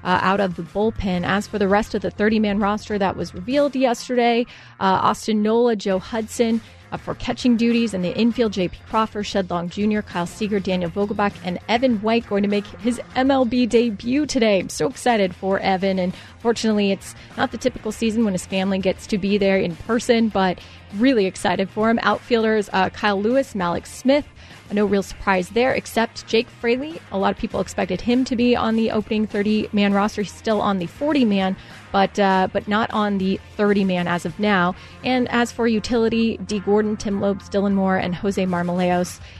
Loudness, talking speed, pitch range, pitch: -21 LUFS, 200 wpm, 195-230 Hz, 210 Hz